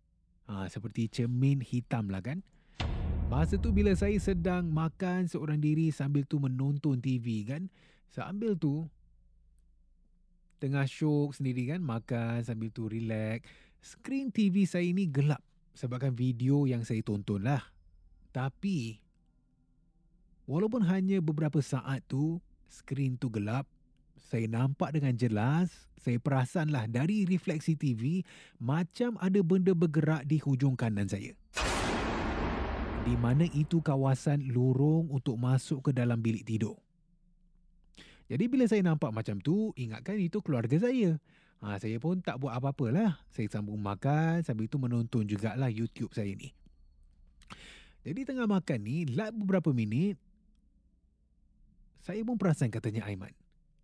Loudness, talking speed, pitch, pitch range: -32 LUFS, 130 wpm, 140 Hz, 115-175 Hz